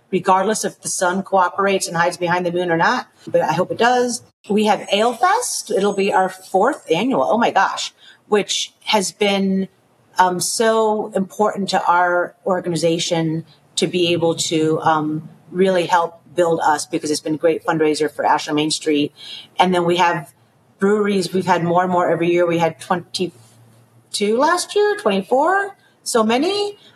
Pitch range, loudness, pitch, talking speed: 165-205 Hz, -18 LUFS, 180 Hz, 170 wpm